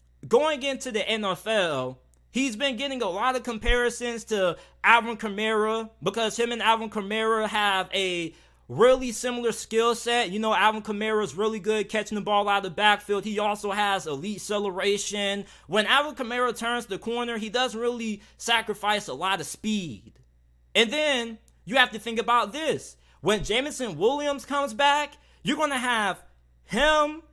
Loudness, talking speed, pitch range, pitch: -25 LUFS, 165 wpm, 205-245 Hz, 220 Hz